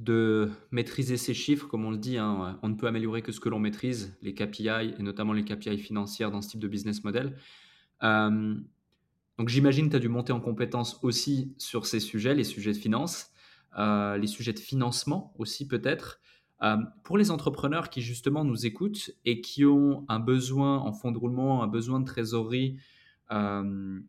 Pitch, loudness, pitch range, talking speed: 115 Hz, -29 LUFS, 105-130 Hz, 195 wpm